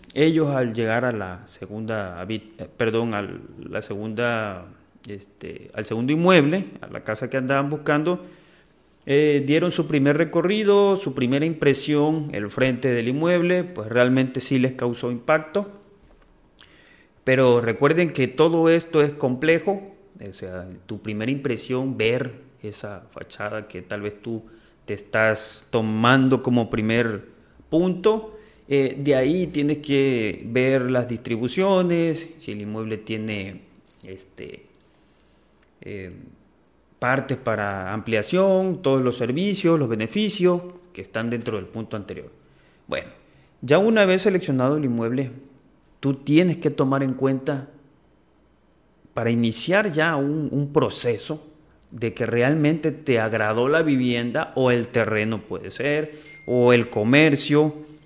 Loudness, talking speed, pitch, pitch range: -22 LUFS, 130 wpm, 130 Hz, 110-155 Hz